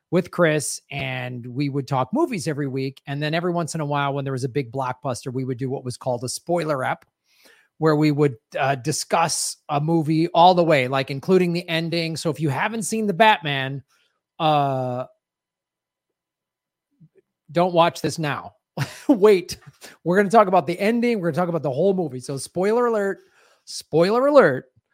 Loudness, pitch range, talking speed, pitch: -21 LUFS, 140-180 Hz, 190 wpm, 160 Hz